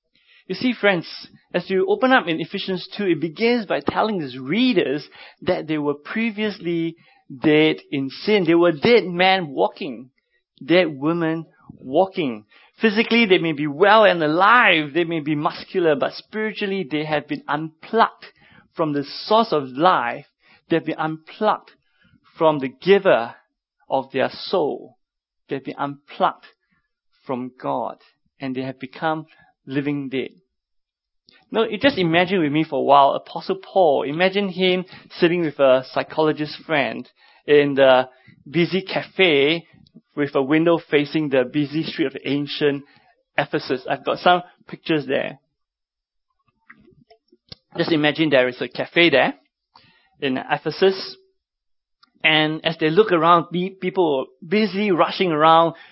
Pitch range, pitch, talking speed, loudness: 145-190 Hz, 165 Hz, 140 wpm, -20 LUFS